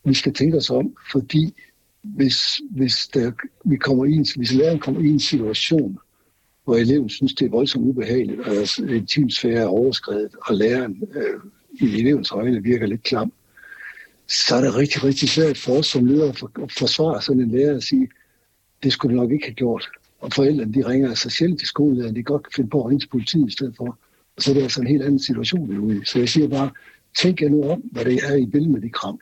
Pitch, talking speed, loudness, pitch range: 135 Hz, 230 wpm, -20 LUFS, 125-150 Hz